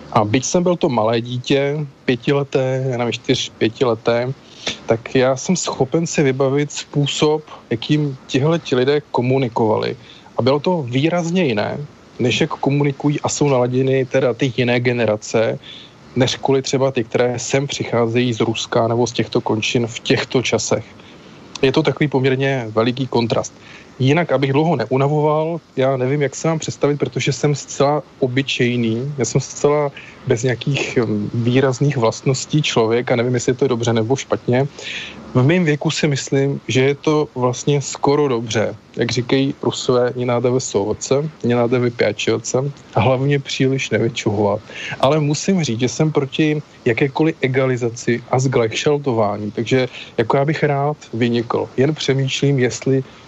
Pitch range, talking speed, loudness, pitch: 120-145 Hz, 150 wpm, -18 LUFS, 130 Hz